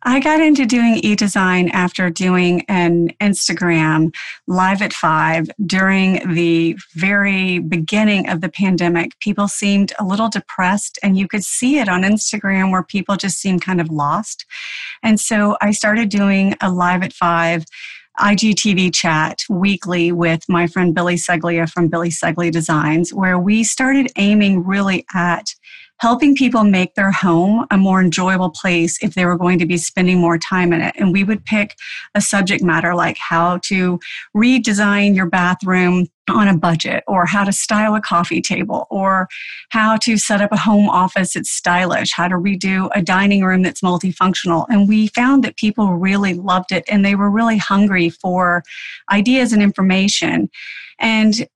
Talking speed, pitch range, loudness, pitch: 170 wpm, 175-205 Hz, -15 LUFS, 190 Hz